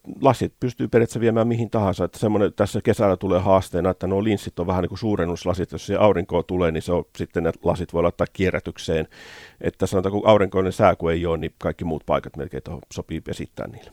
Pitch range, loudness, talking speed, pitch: 85-100 Hz, -22 LUFS, 200 wpm, 90 Hz